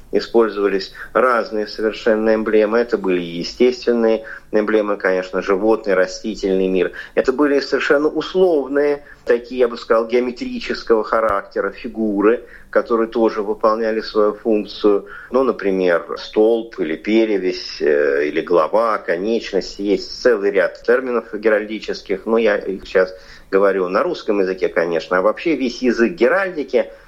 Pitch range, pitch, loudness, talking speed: 105-145 Hz, 115 Hz, -18 LUFS, 120 wpm